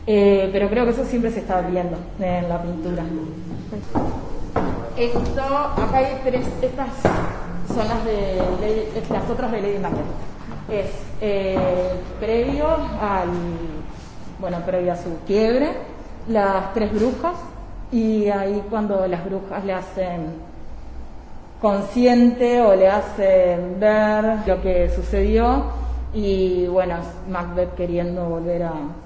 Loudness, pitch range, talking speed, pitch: -21 LUFS, 175-220 Hz, 120 wpm, 195 Hz